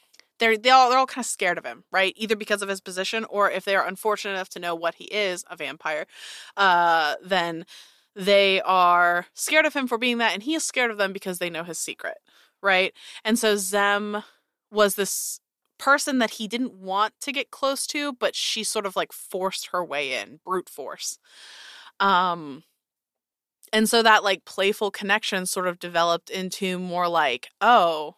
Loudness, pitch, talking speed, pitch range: -23 LUFS, 195 Hz, 190 wpm, 180-225 Hz